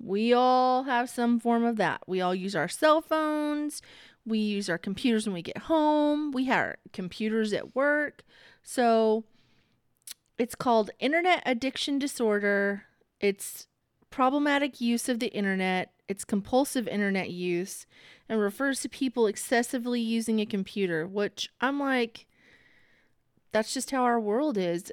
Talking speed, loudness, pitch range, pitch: 145 wpm, -28 LUFS, 205-265 Hz, 235 Hz